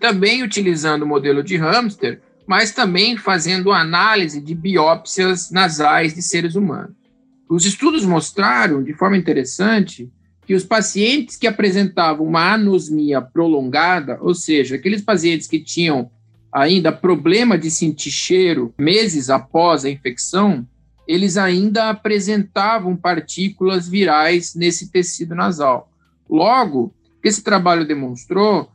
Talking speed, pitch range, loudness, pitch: 120 wpm, 155-200 Hz, -16 LUFS, 180 Hz